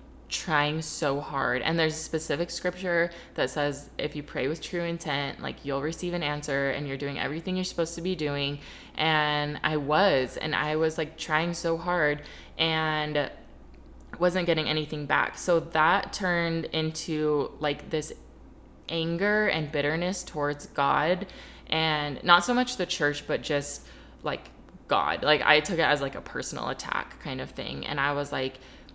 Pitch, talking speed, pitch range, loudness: 155 Hz, 170 wpm, 145-170 Hz, -28 LUFS